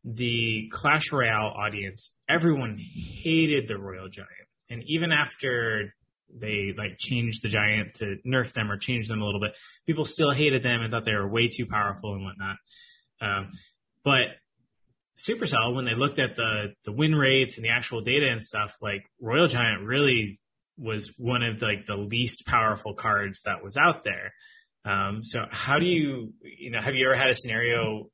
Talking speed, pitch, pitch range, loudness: 185 wpm, 115 Hz, 105-135 Hz, -26 LUFS